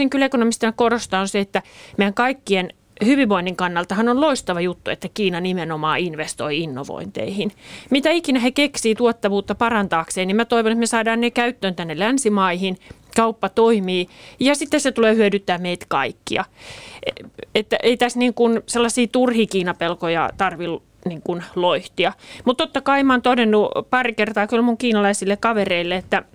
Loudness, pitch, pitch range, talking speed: -20 LUFS, 215 Hz, 185-240 Hz, 155 wpm